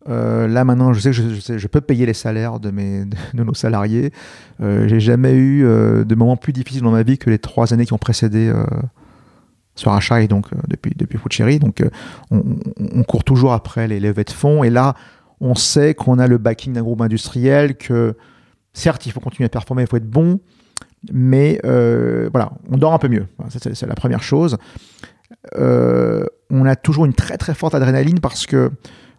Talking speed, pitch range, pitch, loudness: 215 wpm, 115-135 Hz, 120 Hz, -16 LUFS